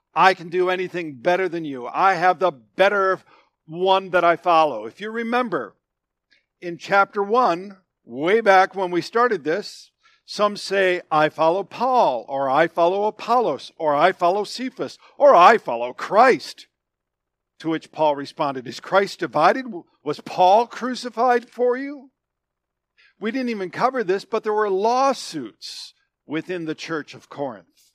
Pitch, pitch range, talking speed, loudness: 185 Hz, 160-220 Hz, 150 wpm, -20 LUFS